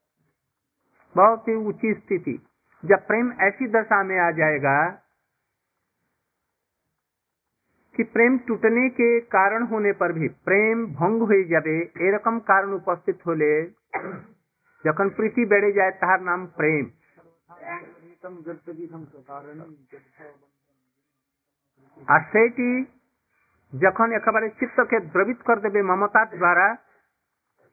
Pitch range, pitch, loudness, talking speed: 160-225 Hz, 190 Hz, -21 LUFS, 95 wpm